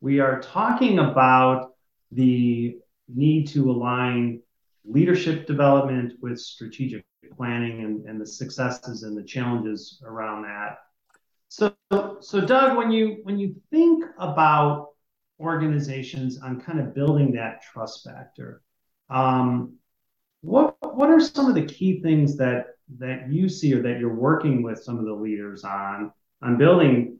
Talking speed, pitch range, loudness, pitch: 140 wpm, 120-160 Hz, -22 LUFS, 130 Hz